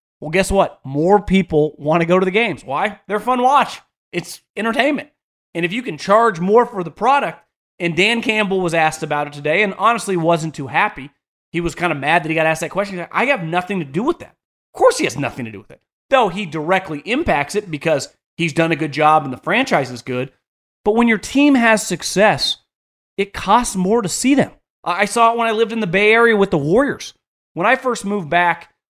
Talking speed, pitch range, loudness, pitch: 240 wpm, 160-225 Hz, -17 LUFS, 190 Hz